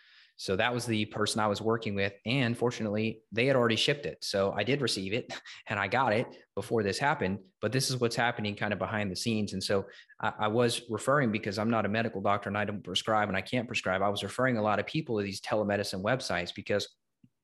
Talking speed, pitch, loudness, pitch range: 235 wpm, 105 Hz, -30 LUFS, 100-115 Hz